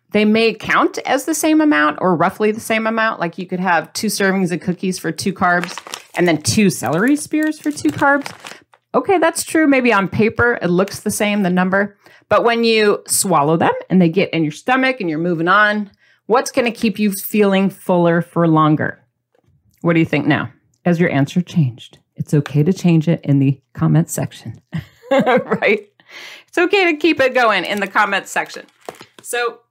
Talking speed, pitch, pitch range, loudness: 195 wpm, 195 Hz, 170-235 Hz, -16 LUFS